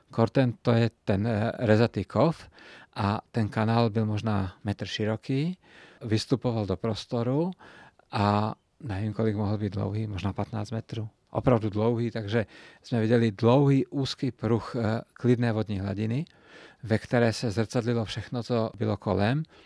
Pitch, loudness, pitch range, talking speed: 115 Hz, -28 LUFS, 110-120 Hz, 140 wpm